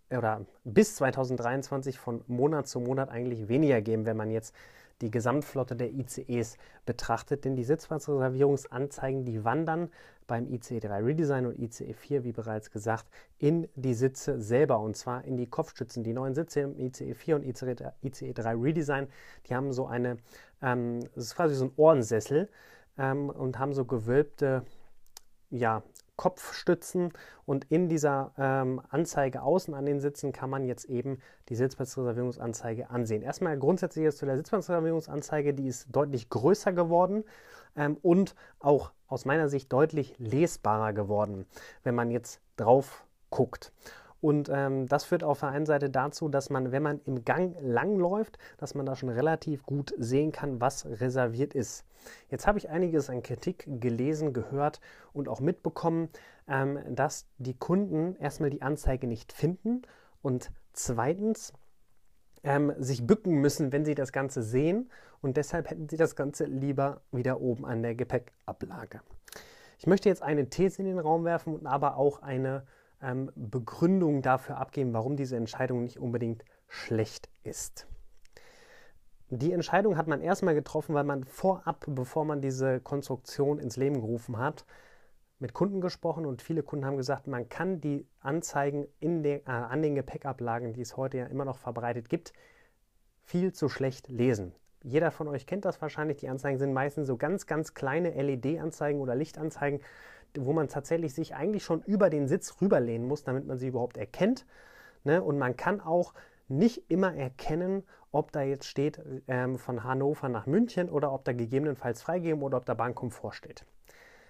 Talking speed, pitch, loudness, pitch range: 165 wpm, 140 Hz, -31 LUFS, 125-155 Hz